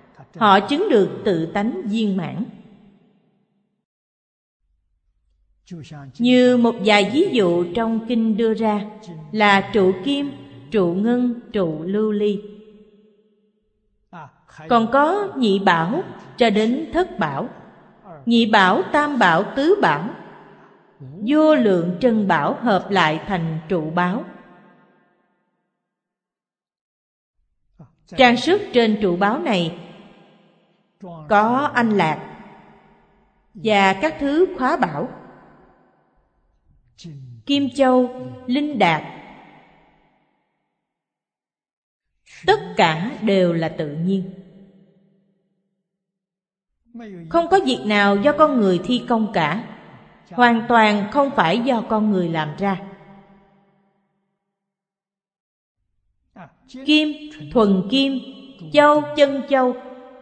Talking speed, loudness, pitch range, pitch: 95 wpm, -18 LUFS, 185-240 Hz, 205 Hz